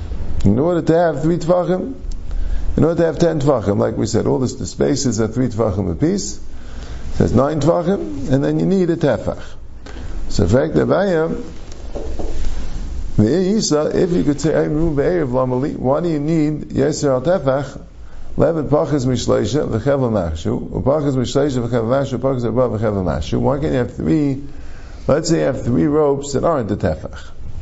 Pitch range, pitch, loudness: 95-150 Hz, 130 Hz, -18 LUFS